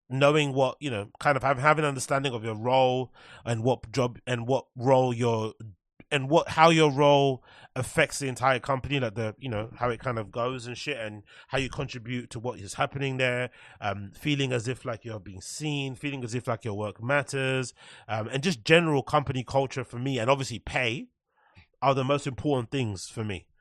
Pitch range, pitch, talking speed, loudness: 115-140 Hz, 130 Hz, 205 wpm, -27 LUFS